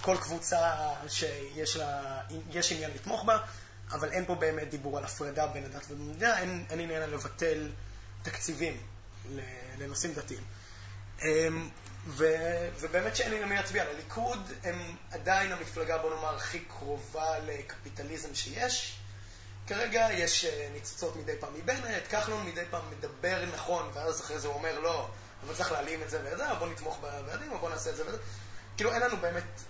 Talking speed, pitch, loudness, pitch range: 155 wpm, 155 Hz, -34 LUFS, 105-170 Hz